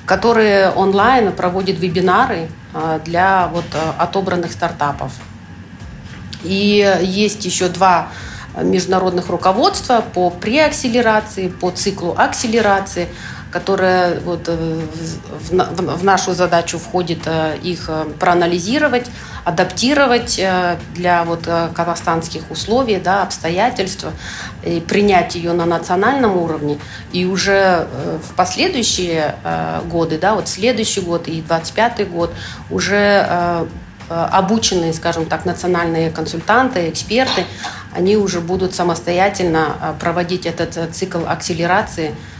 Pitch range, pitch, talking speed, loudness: 165-195 Hz, 180 Hz, 95 wpm, -16 LUFS